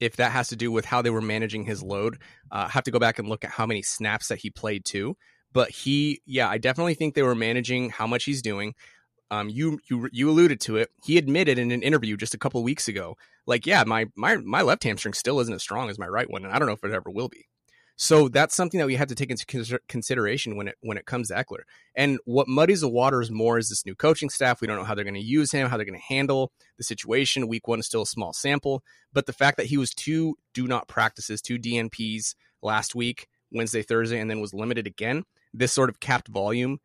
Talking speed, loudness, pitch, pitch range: 260 wpm, -25 LUFS, 120 Hz, 110-140 Hz